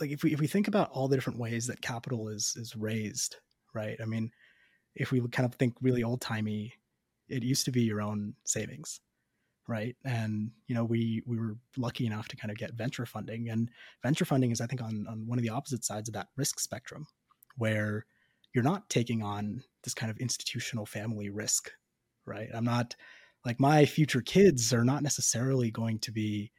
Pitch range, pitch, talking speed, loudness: 110-130 Hz, 115 Hz, 205 wpm, -32 LUFS